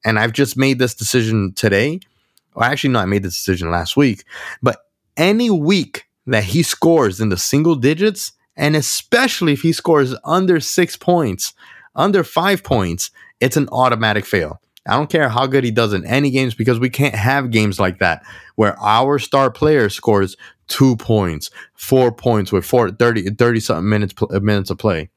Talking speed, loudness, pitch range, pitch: 180 wpm, -16 LUFS, 105-150 Hz, 125 Hz